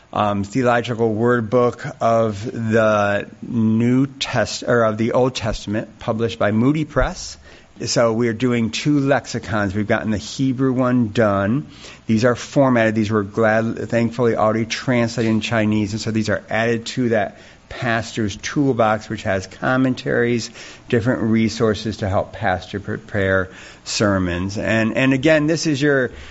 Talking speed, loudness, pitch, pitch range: 150 wpm, -19 LUFS, 115 Hz, 105-125 Hz